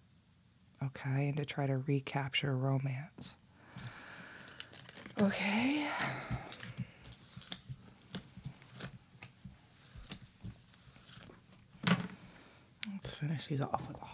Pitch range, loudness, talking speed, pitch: 135-190 Hz, -38 LUFS, 60 wpm, 140 Hz